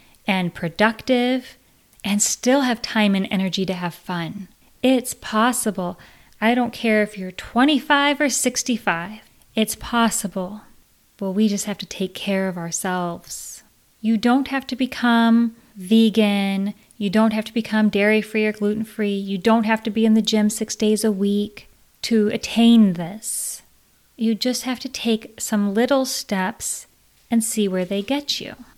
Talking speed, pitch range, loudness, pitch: 160 wpm, 200-235 Hz, -21 LUFS, 220 Hz